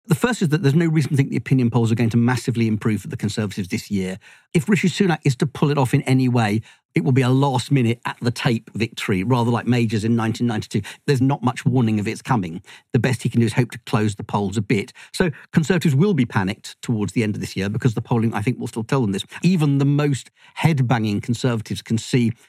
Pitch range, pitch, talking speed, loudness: 115-140 Hz, 125 Hz, 260 wpm, -21 LUFS